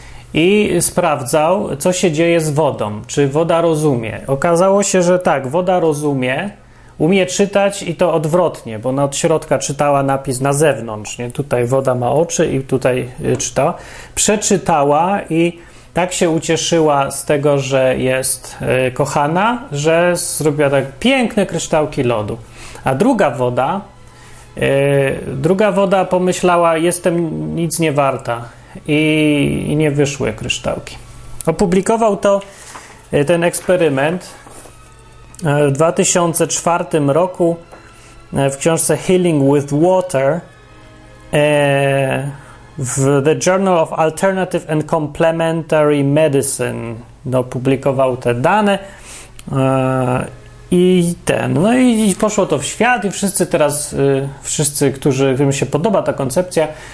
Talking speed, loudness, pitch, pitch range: 115 wpm, -15 LUFS, 155 Hz, 135-175 Hz